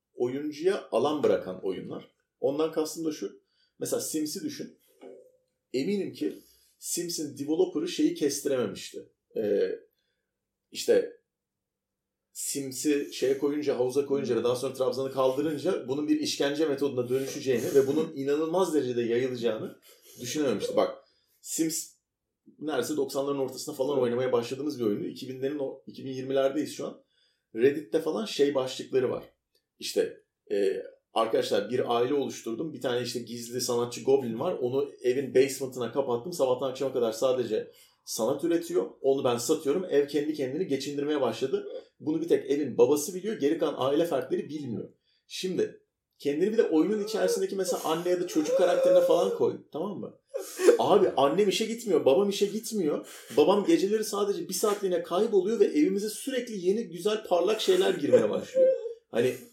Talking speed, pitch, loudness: 140 wpm, 200 Hz, -28 LUFS